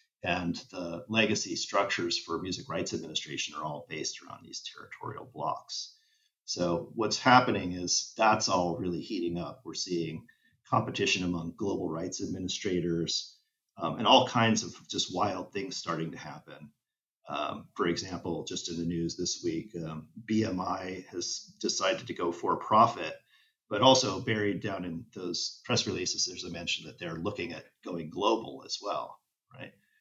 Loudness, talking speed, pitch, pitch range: -31 LUFS, 160 wpm, 95 Hz, 85-130 Hz